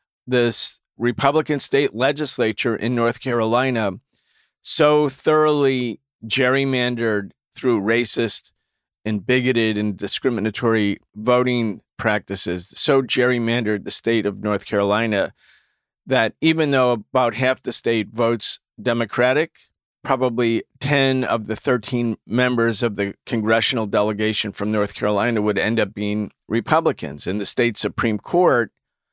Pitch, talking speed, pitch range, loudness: 115 Hz, 115 wpm, 105-125 Hz, -20 LUFS